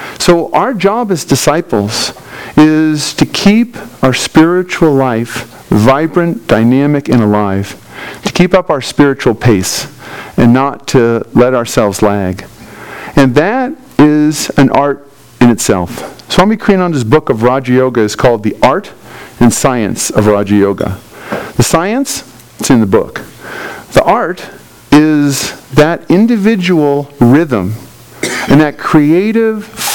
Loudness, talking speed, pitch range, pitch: -10 LUFS, 130 wpm, 120-175 Hz, 145 Hz